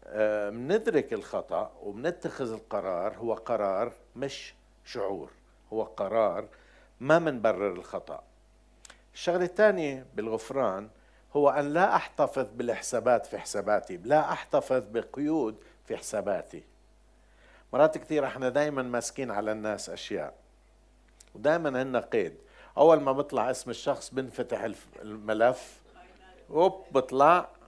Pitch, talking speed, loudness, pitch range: 130 Hz, 100 wpm, -29 LUFS, 110-175 Hz